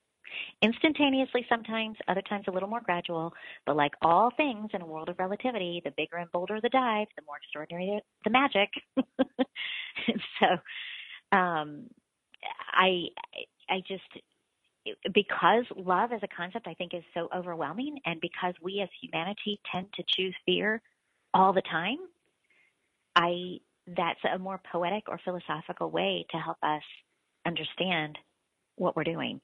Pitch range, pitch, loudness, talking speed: 170-230 Hz, 190 Hz, -30 LUFS, 145 wpm